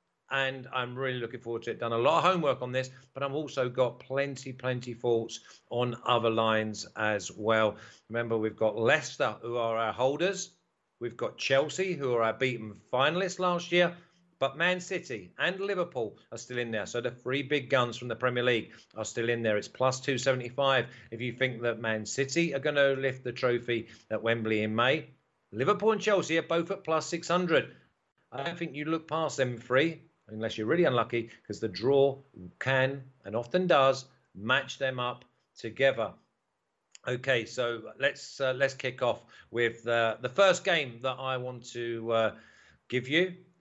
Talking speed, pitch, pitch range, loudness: 185 wpm, 130 Hz, 115-145 Hz, -30 LUFS